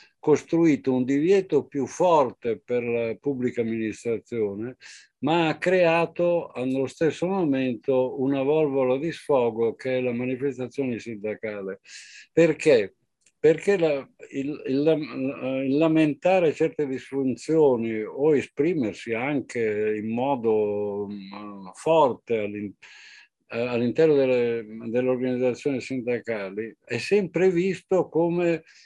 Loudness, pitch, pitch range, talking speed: -24 LUFS, 130 Hz, 115-160 Hz, 105 wpm